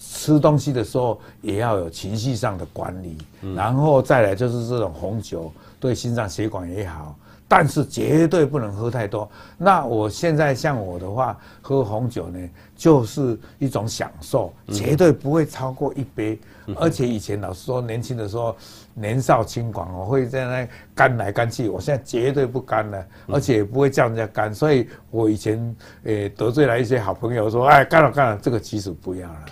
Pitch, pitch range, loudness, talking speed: 115 Hz, 105-135 Hz, -21 LUFS, 270 characters per minute